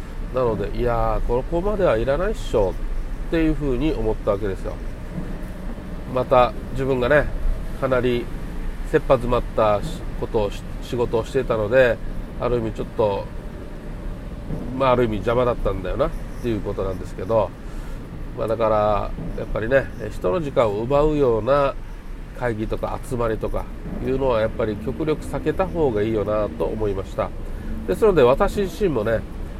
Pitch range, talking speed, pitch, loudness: 105-135 Hz, 320 characters per minute, 120 Hz, -22 LUFS